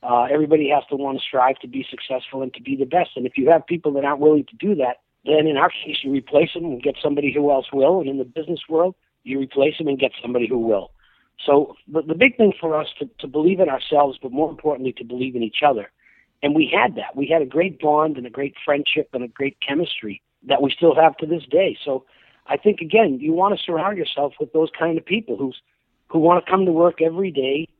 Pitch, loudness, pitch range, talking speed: 150 Hz, -20 LUFS, 135-165 Hz, 255 wpm